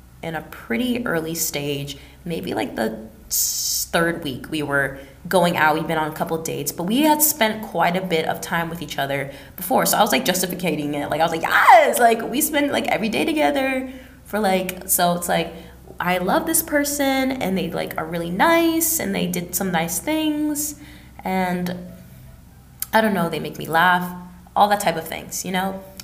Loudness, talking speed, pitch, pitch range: -20 LUFS, 200 wpm, 180 Hz, 160-225 Hz